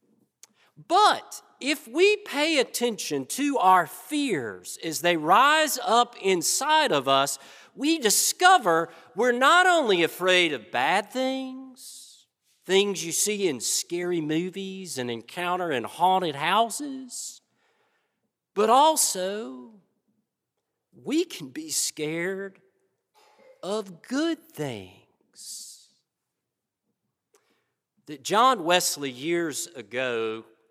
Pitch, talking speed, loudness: 205 Hz, 95 wpm, -24 LUFS